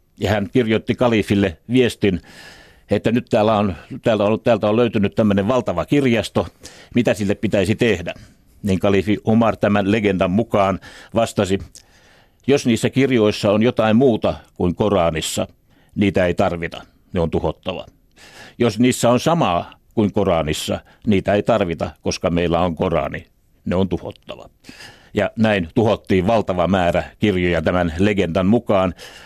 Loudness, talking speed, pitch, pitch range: -19 LUFS, 130 wpm, 105 Hz, 95-115 Hz